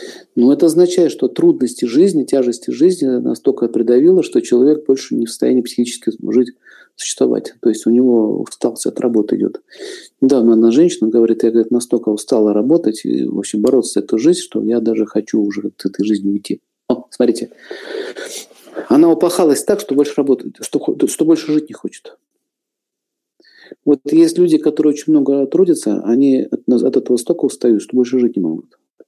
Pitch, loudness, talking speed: 150 Hz, -15 LUFS, 170 wpm